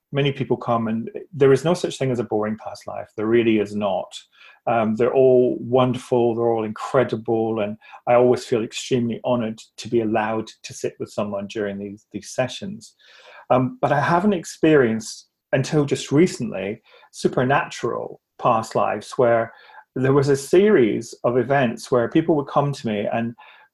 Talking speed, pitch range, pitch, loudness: 170 wpm, 110-135 Hz, 120 Hz, -21 LUFS